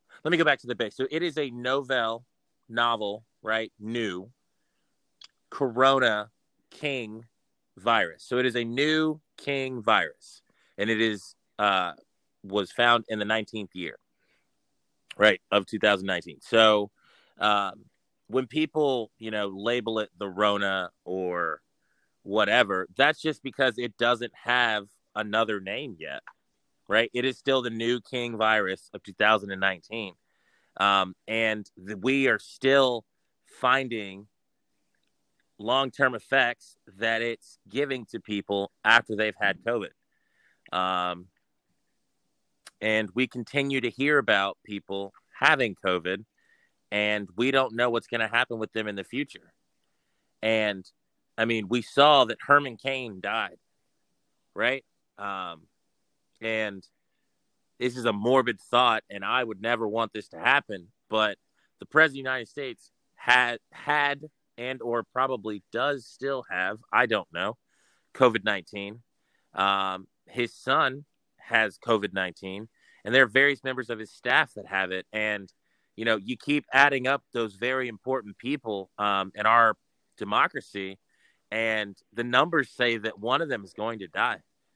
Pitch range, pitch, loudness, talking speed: 105-130 Hz, 115 Hz, -26 LUFS, 140 wpm